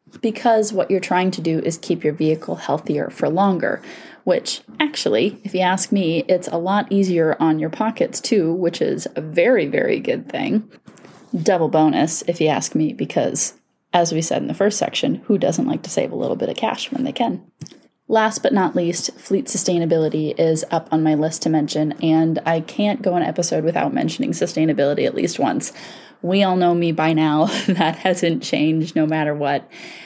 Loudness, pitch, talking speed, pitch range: -19 LUFS, 170 Hz, 195 wpm, 160-200 Hz